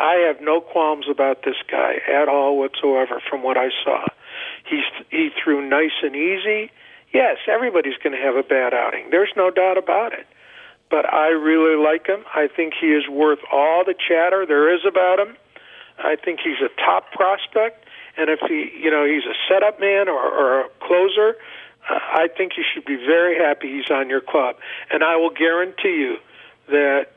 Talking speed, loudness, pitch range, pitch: 190 wpm, -19 LUFS, 150-205 Hz, 170 Hz